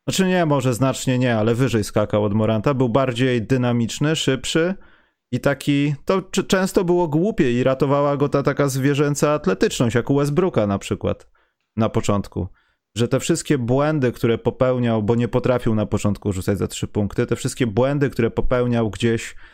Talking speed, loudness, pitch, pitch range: 170 wpm, -20 LUFS, 125 Hz, 115-145 Hz